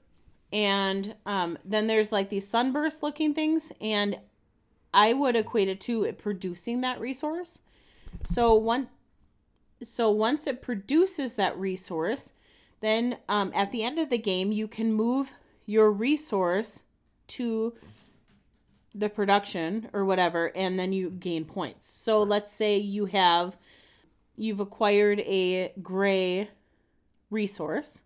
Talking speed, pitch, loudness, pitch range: 130 wpm, 210 Hz, -27 LUFS, 190-235 Hz